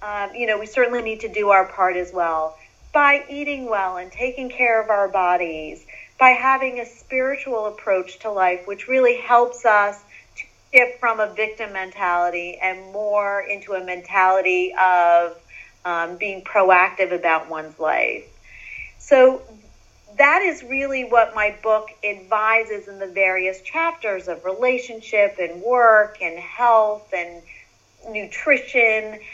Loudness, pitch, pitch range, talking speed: -19 LUFS, 210 Hz, 185-240 Hz, 140 wpm